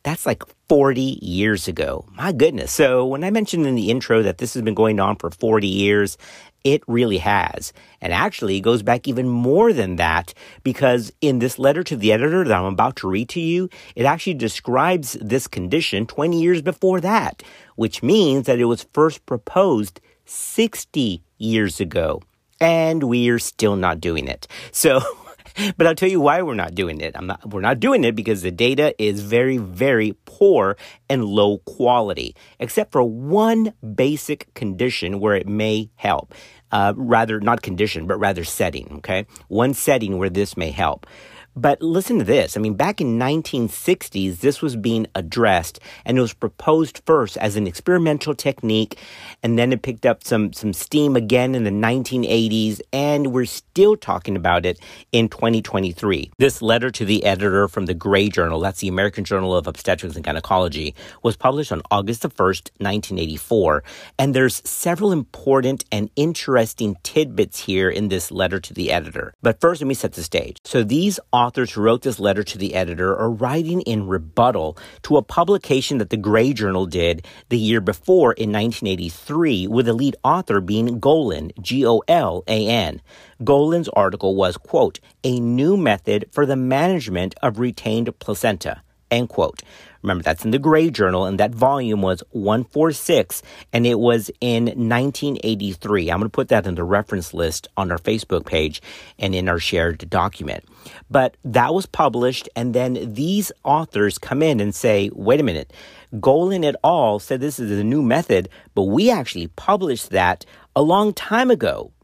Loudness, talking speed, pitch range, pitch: -19 LUFS, 175 wpm, 100-135 Hz, 115 Hz